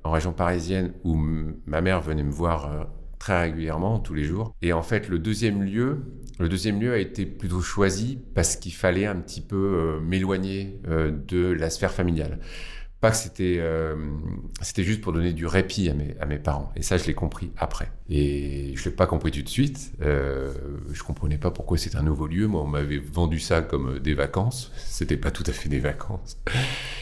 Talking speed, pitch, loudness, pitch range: 210 wpm, 85 Hz, -26 LUFS, 75-95 Hz